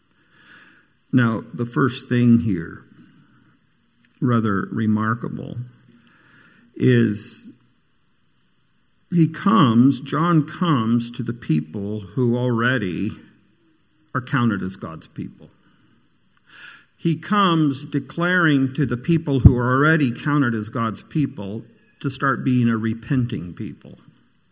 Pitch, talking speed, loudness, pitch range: 125 Hz, 100 wpm, -20 LUFS, 115-145 Hz